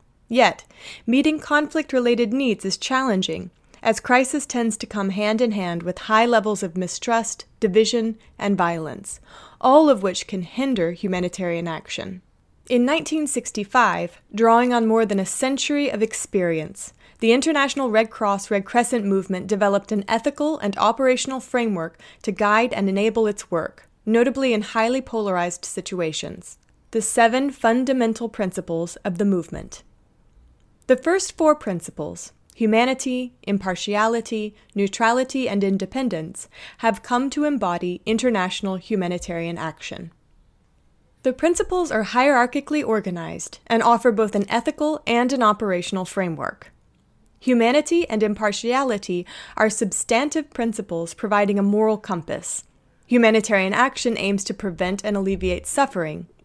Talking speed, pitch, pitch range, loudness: 125 wpm, 220 Hz, 195-250 Hz, -21 LUFS